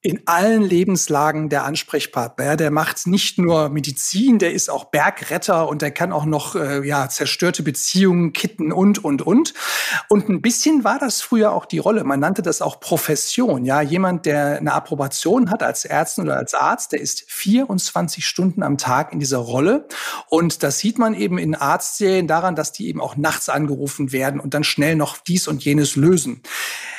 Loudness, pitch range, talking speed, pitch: -19 LUFS, 145-195 Hz, 190 wpm, 160 Hz